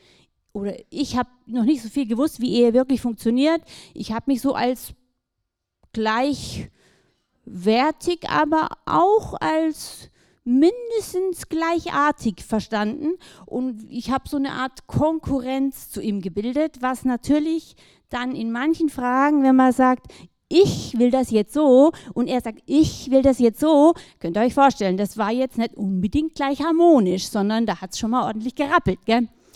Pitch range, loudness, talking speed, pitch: 225-295 Hz, -21 LUFS, 155 wpm, 255 Hz